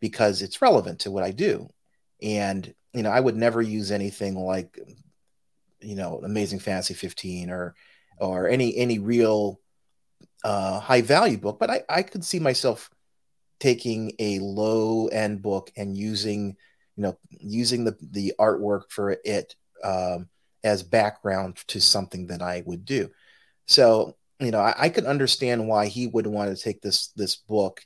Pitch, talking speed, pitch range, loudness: 105 Hz, 165 wpm, 95-110 Hz, -24 LUFS